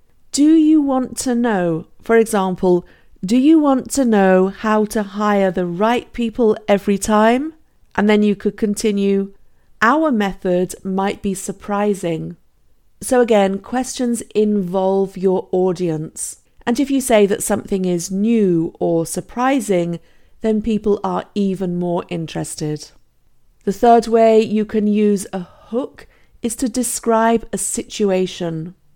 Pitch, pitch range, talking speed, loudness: 205 Hz, 185-230 Hz, 135 wpm, -17 LUFS